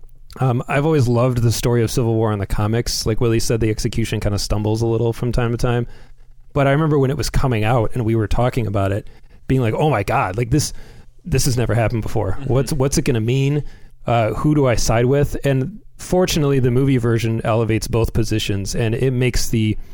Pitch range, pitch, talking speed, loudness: 110-135 Hz, 120 Hz, 230 wpm, -19 LUFS